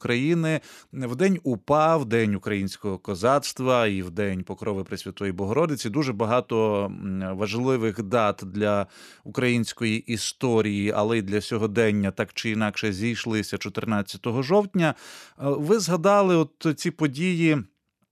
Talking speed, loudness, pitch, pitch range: 120 wpm, -25 LUFS, 115 Hz, 105-140 Hz